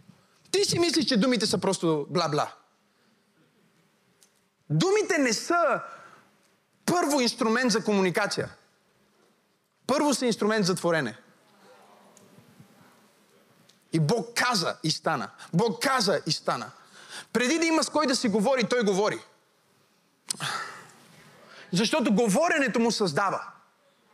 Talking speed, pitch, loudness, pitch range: 105 wpm, 210 Hz, -25 LUFS, 190-255 Hz